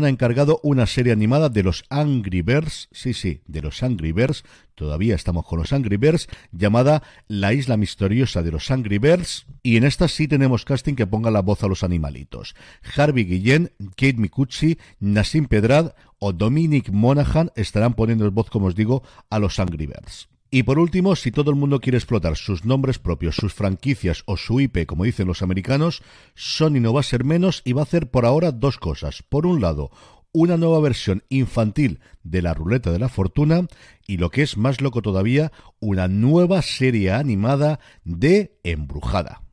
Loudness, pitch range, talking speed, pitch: -20 LUFS, 100-145 Hz, 185 wpm, 120 Hz